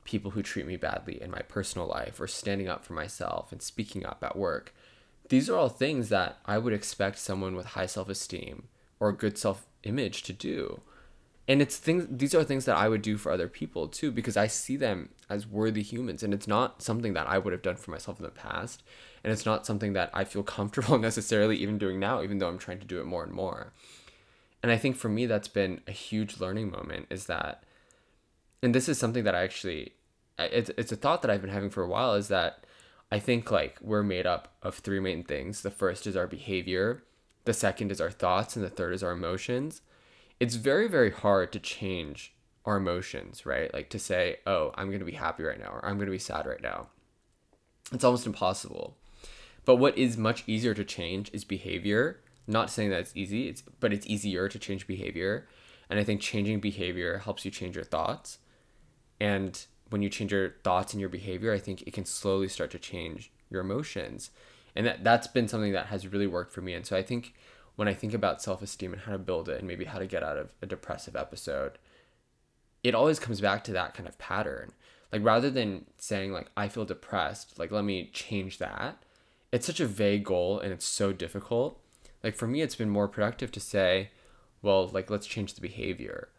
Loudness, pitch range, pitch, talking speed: -31 LUFS, 95-115 Hz, 105 Hz, 220 wpm